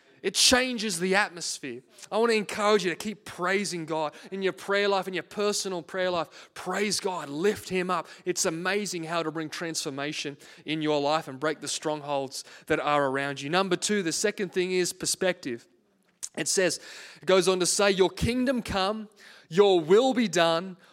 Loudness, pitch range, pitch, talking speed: -27 LUFS, 160-200 Hz, 185 Hz, 185 wpm